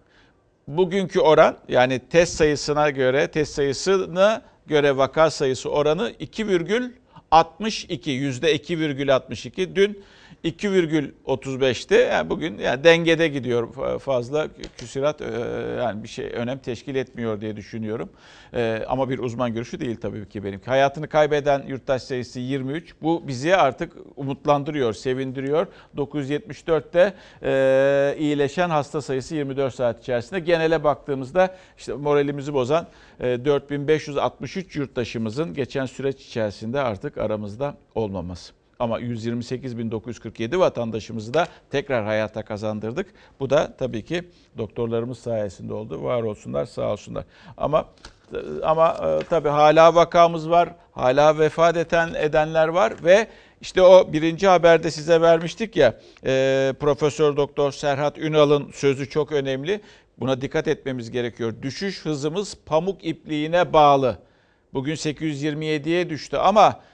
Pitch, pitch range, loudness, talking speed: 145 Hz, 125-160 Hz, -22 LUFS, 115 wpm